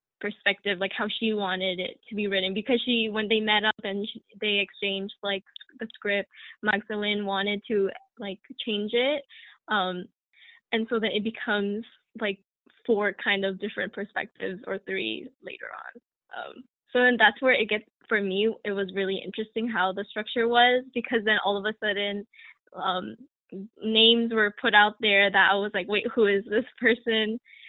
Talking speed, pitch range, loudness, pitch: 180 wpm, 200-230 Hz, -26 LUFS, 210 Hz